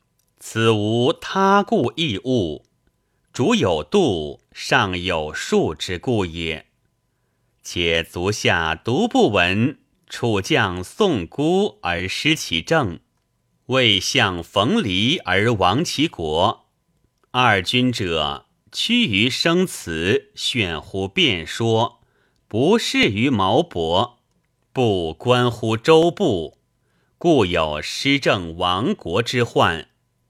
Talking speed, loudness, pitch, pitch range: 130 characters per minute, -19 LUFS, 120 Hz, 90-130 Hz